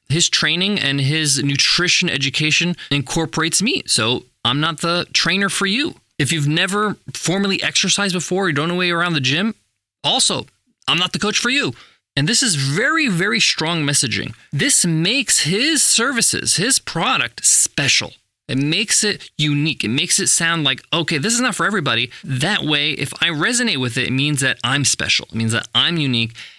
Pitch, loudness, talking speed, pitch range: 165 Hz, -16 LUFS, 185 wpm, 140-195 Hz